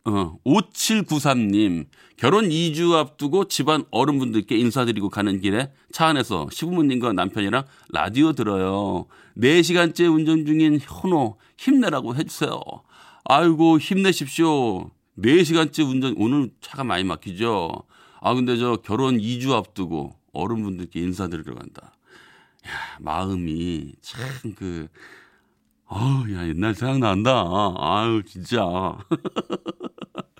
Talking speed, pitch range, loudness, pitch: 245 characters per minute, 100-155 Hz, -22 LUFS, 125 Hz